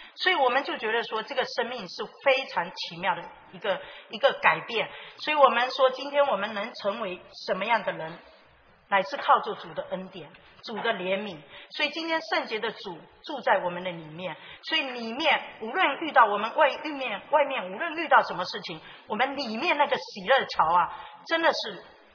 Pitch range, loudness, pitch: 200-285 Hz, -26 LUFS, 250 Hz